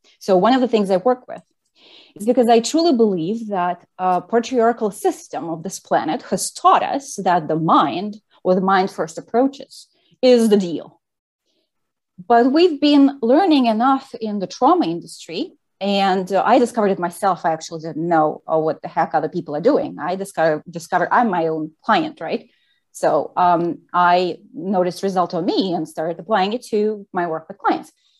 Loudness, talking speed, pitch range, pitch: -19 LUFS, 180 wpm, 175-245 Hz, 195 Hz